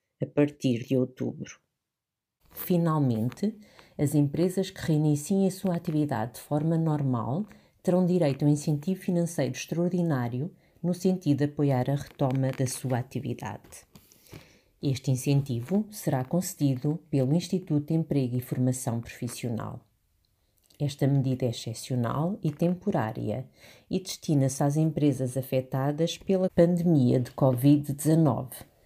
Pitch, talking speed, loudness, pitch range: 145 Hz, 120 wpm, -28 LUFS, 130-170 Hz